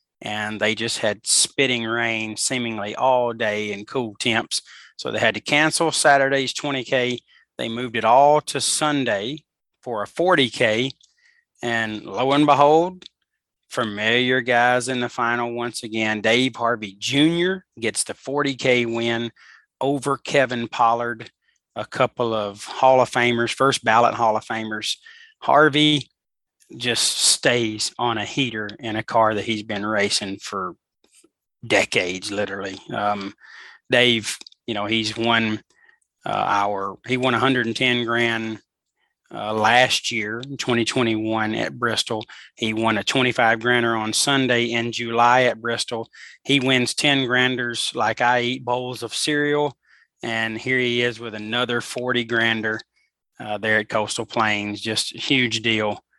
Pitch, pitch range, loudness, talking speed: 120 Hz, 110-130 Hz, -21 LUFS, 140 wpm